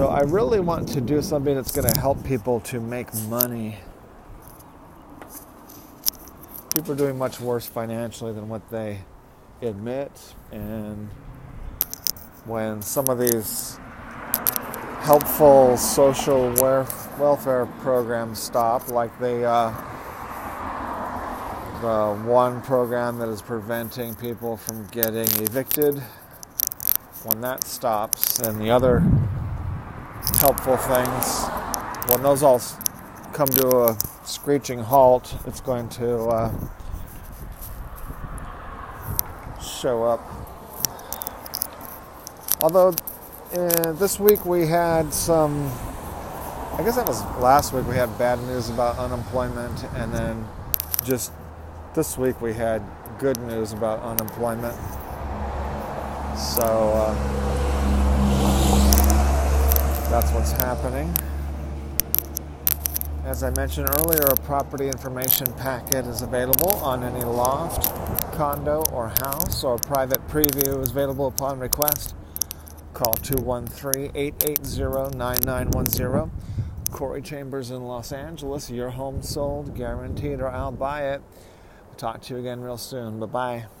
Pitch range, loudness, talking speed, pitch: 100-135 Hz, -23 LUFS, 110 wpm, 120 Hz